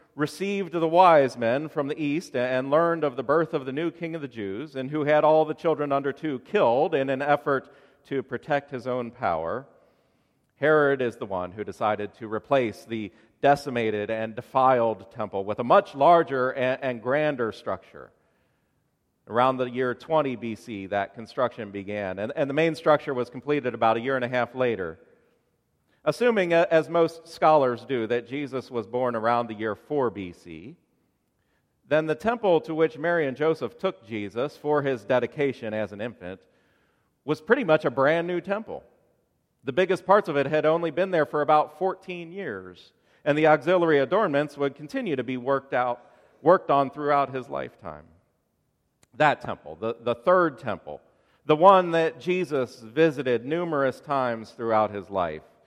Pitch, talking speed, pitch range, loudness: 140 Hz, 170 wpm, 120-155 Hz, -25 LUFS